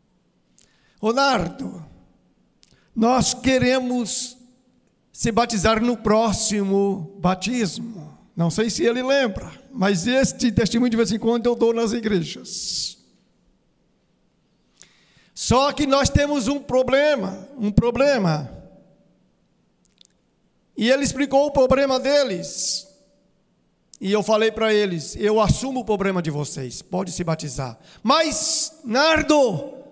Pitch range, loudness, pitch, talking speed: 190-260 Hz, -21 LUFS, 230 Hz, 110 wpm